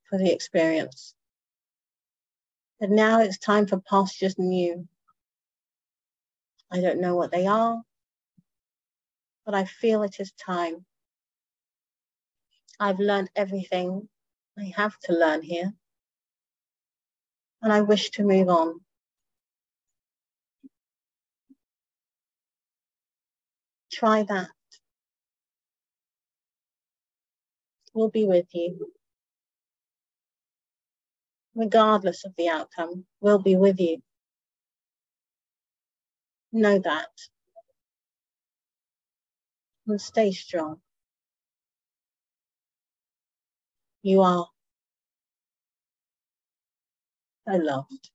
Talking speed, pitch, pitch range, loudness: 75 wpm, 195 Hz, 175-210 Hz, -24 LUFS